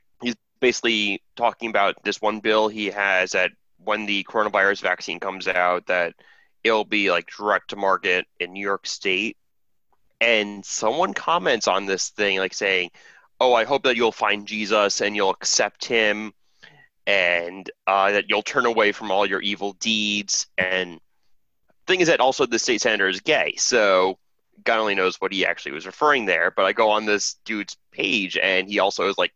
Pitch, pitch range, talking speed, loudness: 100 Hz, 95-110 Hz, 180 wpm, -21 LUFS